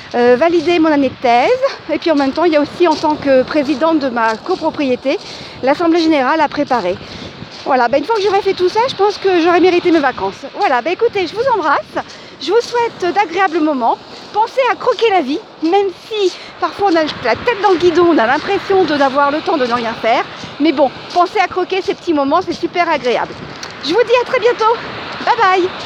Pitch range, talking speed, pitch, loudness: 290-395 Hz, 225 wpm, 345 Hz, -14 LUFS